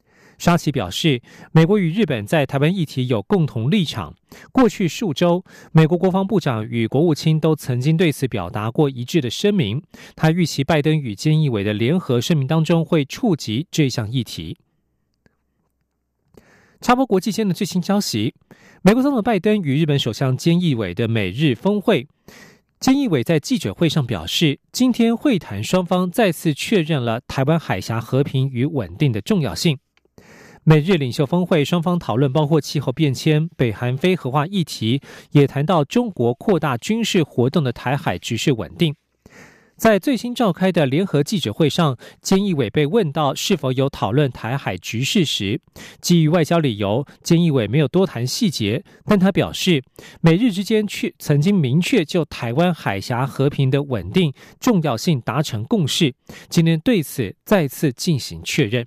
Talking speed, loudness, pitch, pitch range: 260 characters per minute, -19 LUFS, 155 Hz, 130-180 Hz